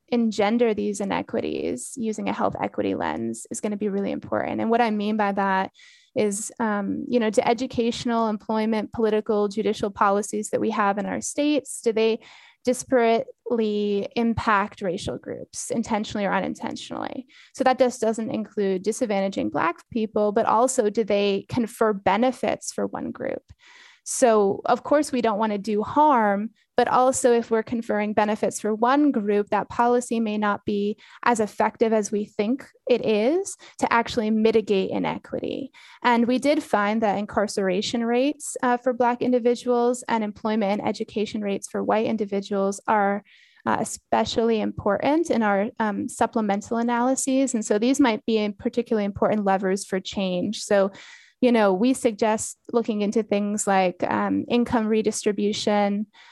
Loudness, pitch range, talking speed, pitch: -24 LUFS, 205-245 Hz, 155 wpm, 220 Hz